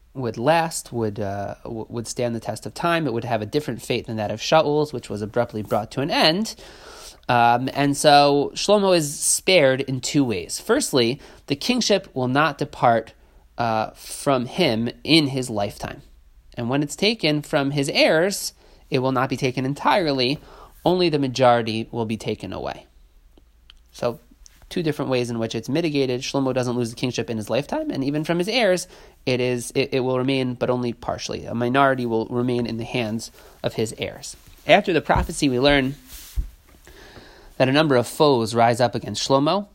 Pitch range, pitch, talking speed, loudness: 115-145 Hz, 125 Hz, 185 wpm, -21 LUFS